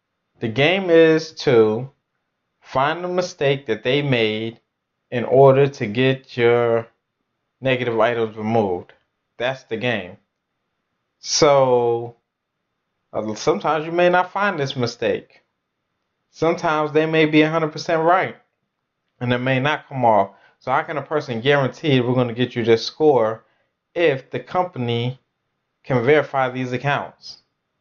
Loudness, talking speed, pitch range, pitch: -19 LUFS, 130 wpm, 120-155 Hz, 130 Hz